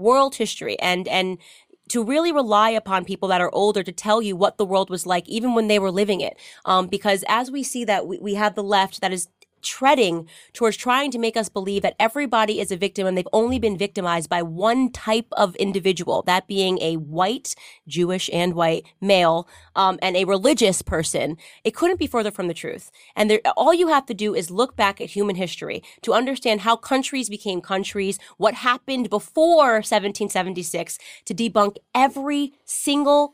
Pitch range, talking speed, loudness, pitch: 185-235 Hz, 195 wpm, -21 LUFS, 205 Hz